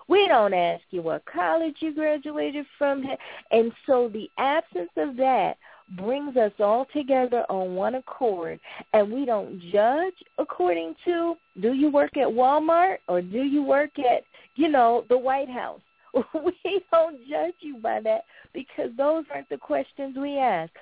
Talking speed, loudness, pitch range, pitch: 160 wpm, -25 LUFS, 215-310 Hz, 265 Hz